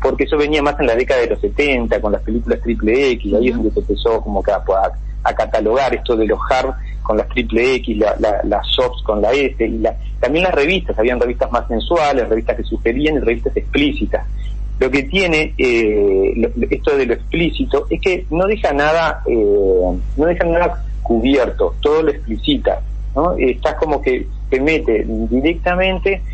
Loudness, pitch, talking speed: -16 LUFS, 185 Hz, 190 wpm